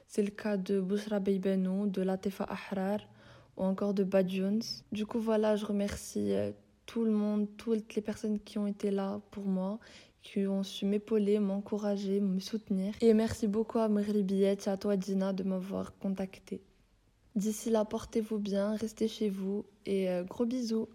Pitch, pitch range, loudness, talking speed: 205 Hz, 195-215 Hz, -33 LUFS, 170 wpm